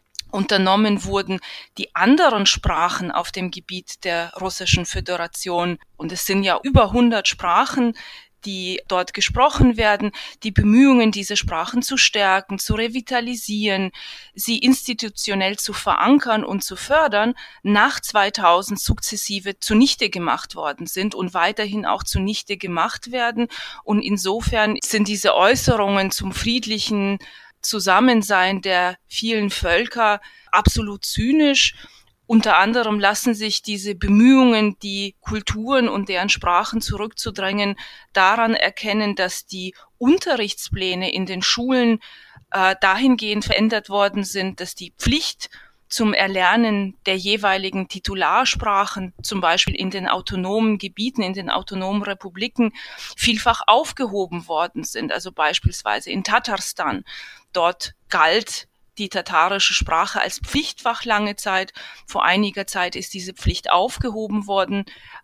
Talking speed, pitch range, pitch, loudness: 120 wpm, 190-225 Hz, 205 Hz, -19 LUFS